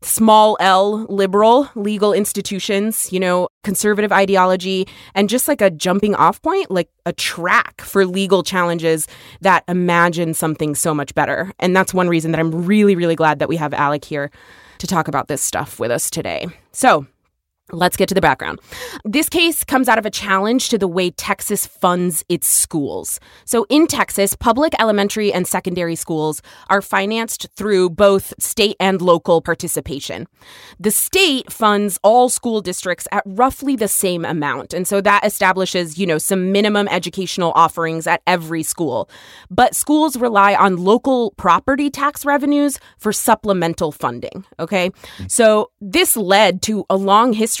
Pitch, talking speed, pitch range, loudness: 195 Hz, 165 wpm, 170-215 Hz, -16 LUFS